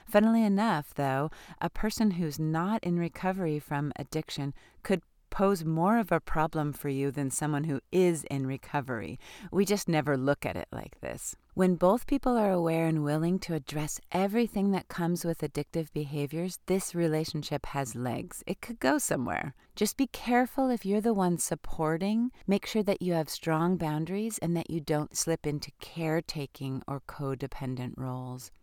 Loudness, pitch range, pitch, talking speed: -30 LUFS, 145-190 Hz, 165 Hz, 170 wpm